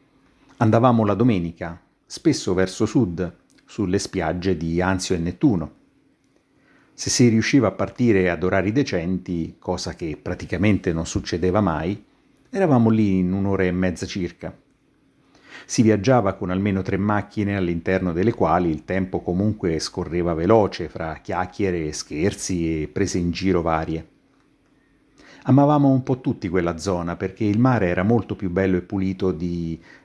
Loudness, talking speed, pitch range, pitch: -22 LUFS, 145 wpm, 90-105 Hz, 95 Hz